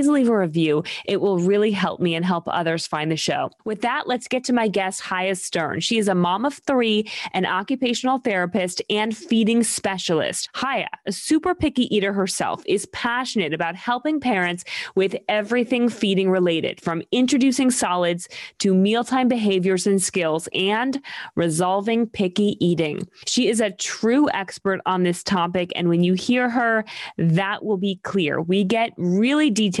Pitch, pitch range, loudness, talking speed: 205 Hz, 180-240 Hz, -21 LUFS, 165 wpm